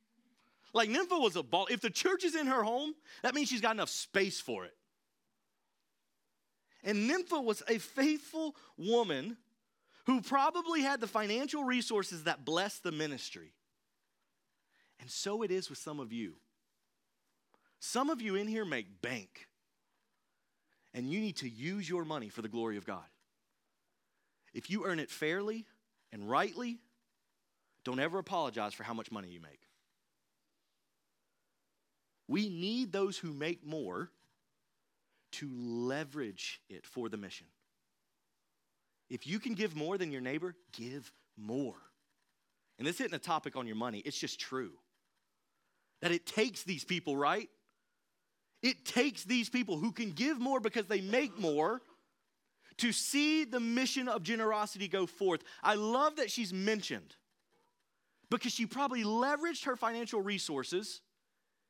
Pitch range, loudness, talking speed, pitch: 155-245 Hz, -36 LUFS, 145 wpm, 210 Hz